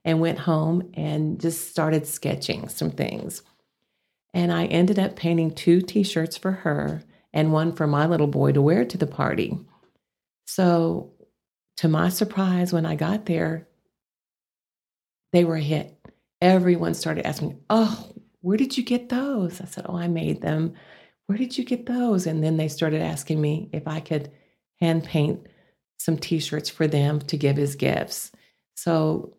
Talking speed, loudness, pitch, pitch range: 165 wpm, -24 LUFS, 165 Hz, 155-180 Hz